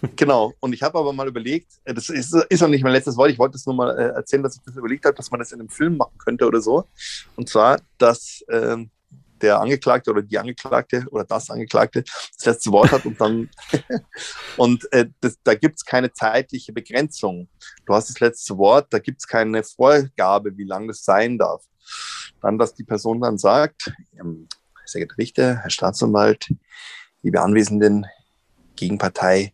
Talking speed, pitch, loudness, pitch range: 190 wpm, 120 Hz, -19 LUFS, 105-135 Hz